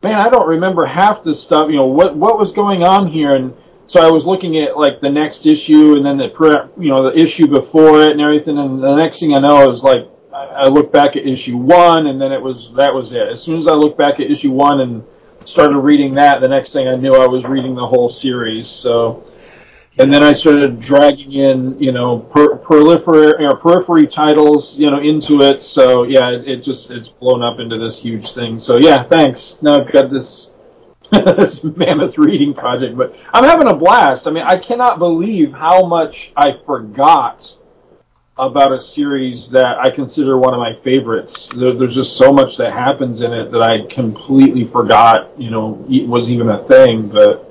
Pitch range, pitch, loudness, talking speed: 130-165 Hz, 140 Hz, -11 LUFS, 205 wpm